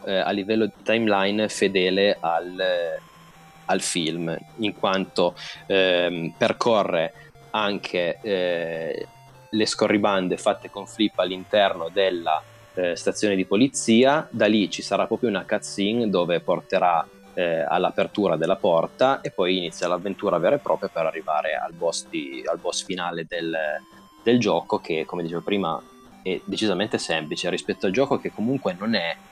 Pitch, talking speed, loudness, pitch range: 95 Hz, 145 wpm, -23 LUFS, 85-110 Hz